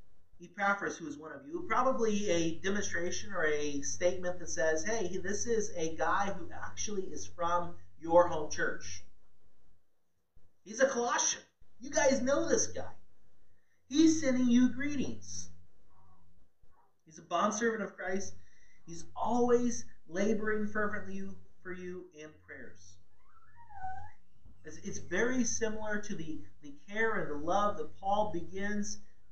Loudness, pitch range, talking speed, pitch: -33 LUFS, 150-220 Hz, 130 wpm, 185 Hz